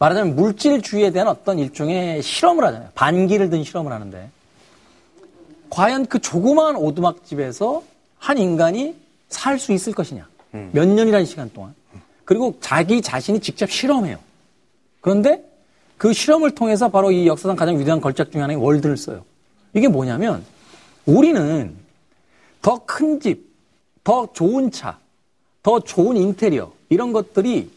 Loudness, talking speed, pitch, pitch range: -18 LUFS, 300 characters per minute, 195 Hz, 160-260 Hz